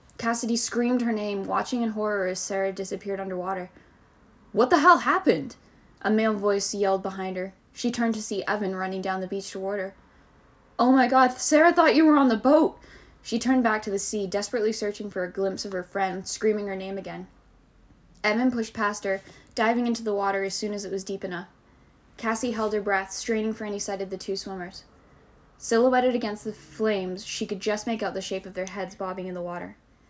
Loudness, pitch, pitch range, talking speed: -26 LUFS, 205 Hz, 195-225 Hz, 210 wpm